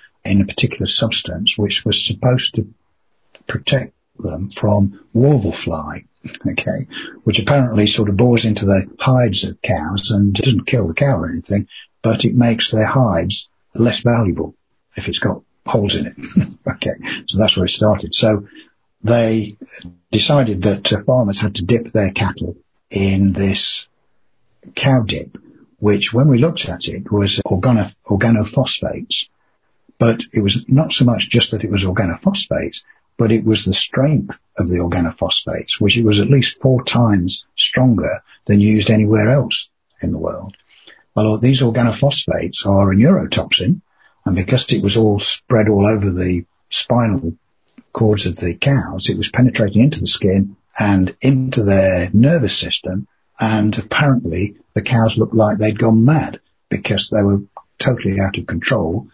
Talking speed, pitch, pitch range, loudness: 155 wpm, 105 Hz, 100-120 Hz, -16 LUFS